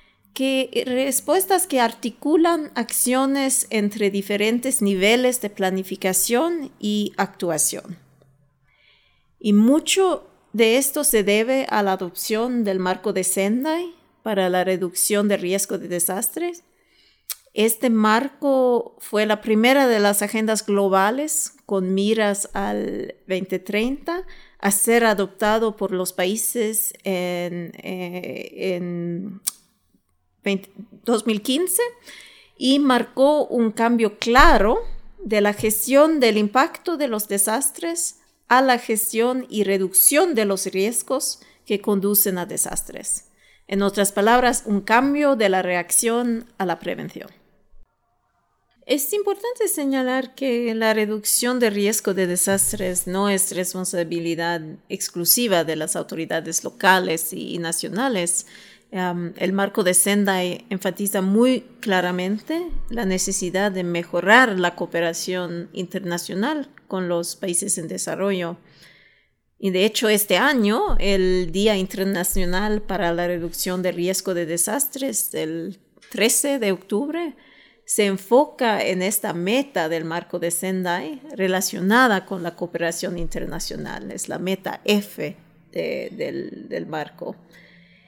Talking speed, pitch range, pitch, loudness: 120 wpm, 185-245 Hz, 205 Hz, -21 LUFS